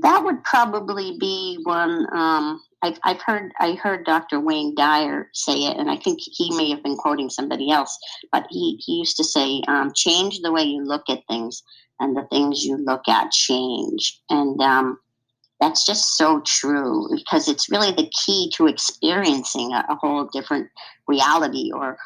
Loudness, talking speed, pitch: -20 LUFS, 180 wpm, 155 Hz